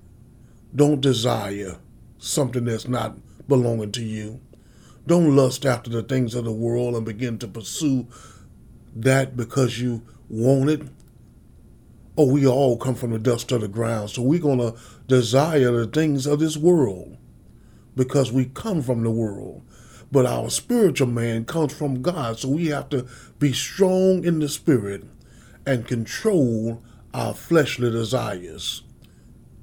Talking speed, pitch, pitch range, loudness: 145 wpm, 125 Hz, 115-140 Hz, -22 LUFS